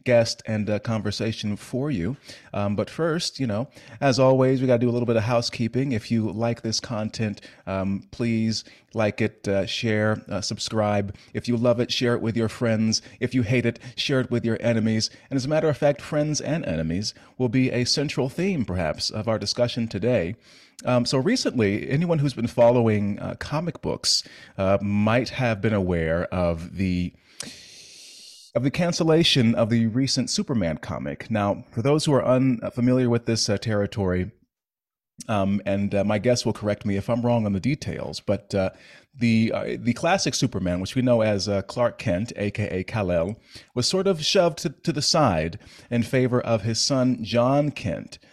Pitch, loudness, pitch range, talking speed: 115 Hz, -24 LUFS, 105-130 Hz, 185 wpm